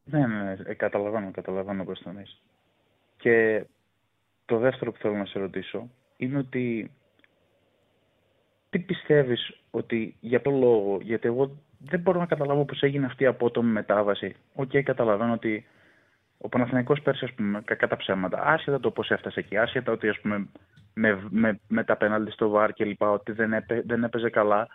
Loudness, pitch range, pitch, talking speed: -26 LUFS, 105-130 Hz, 115 Hz, 175 wpm